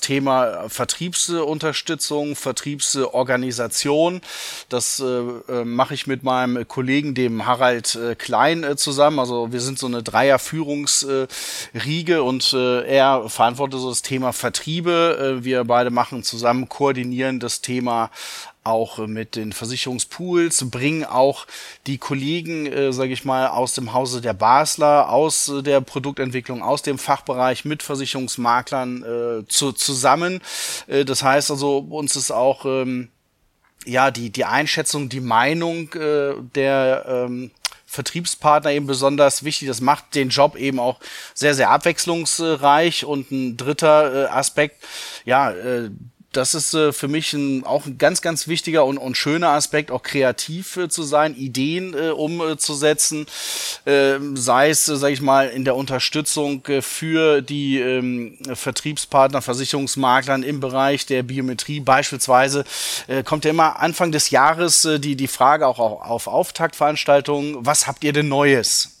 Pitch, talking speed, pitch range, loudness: 135 Hz, 130 wpm, 125-150 Hz, -19 LUFS